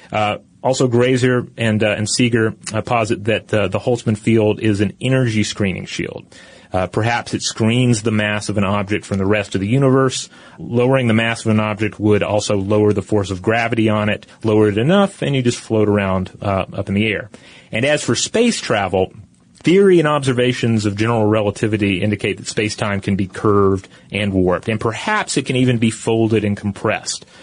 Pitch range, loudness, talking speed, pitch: 105-120 Hz, -17 LUFS, 195 wpm, 110 Hz